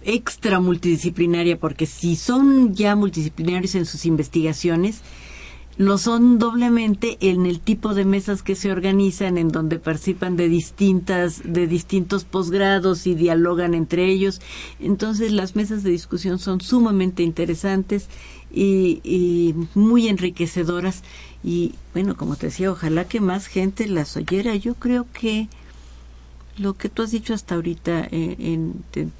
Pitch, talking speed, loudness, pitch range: 185 Hz, 140 wpm, -20 LUFS, 170-200 Hz